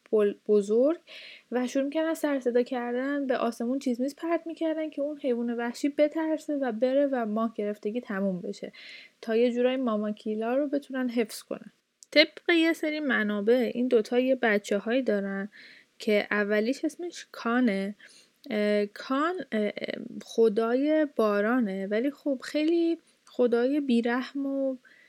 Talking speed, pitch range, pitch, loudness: 140 wpm, 225-285 Hz, 250 Hz, -28 LUFS